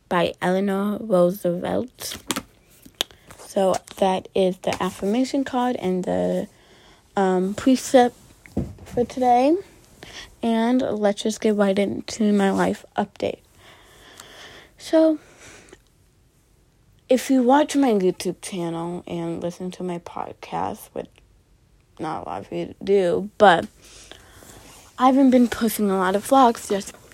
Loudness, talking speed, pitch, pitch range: -22 LUFS, 115 wpm, 200 Hz, 185-245 Hz